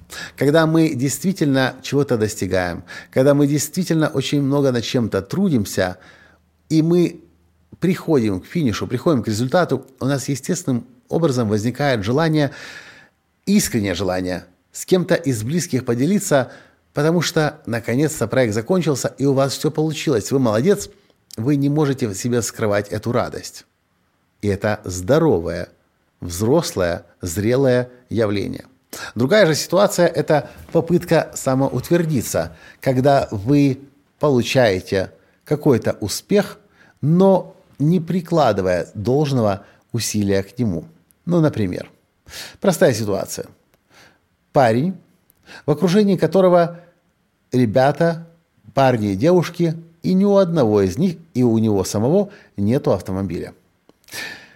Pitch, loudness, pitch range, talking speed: 135 Hz, -19 LUFS, 105-160 Hz, 110 wpm